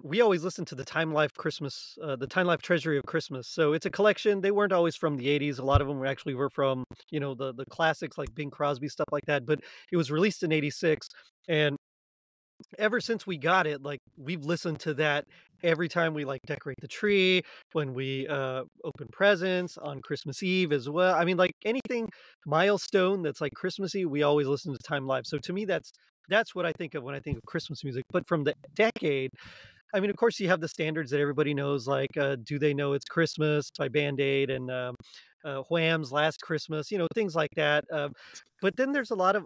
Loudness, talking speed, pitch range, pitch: -29 LUFS, 230 wpm, 140-180 Hz, 155 Hz